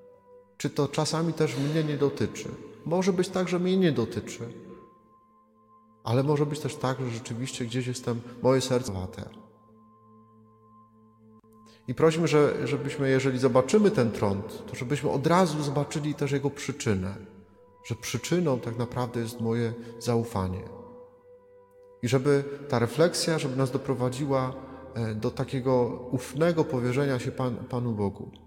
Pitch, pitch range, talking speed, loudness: 130 Hz, 115-150 Hz, 135 wpm, -27 LUFS